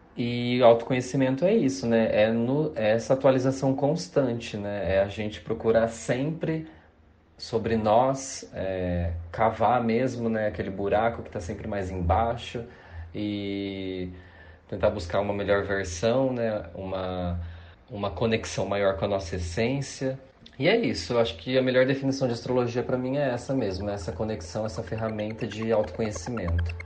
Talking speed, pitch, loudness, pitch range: 150 wpm, 110 Hz, -27 LUFS, 95-125 Hz